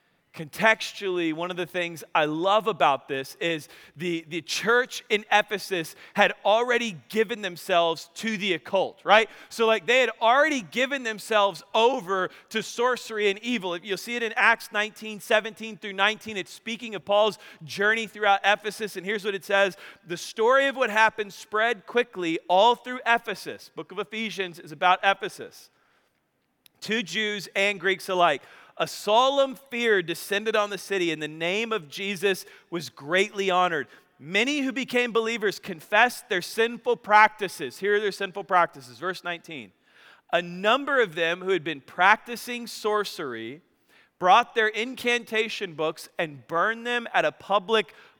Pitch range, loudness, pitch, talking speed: 180-225 Hz, -25 LUFS, 205 Hz, 155 wpm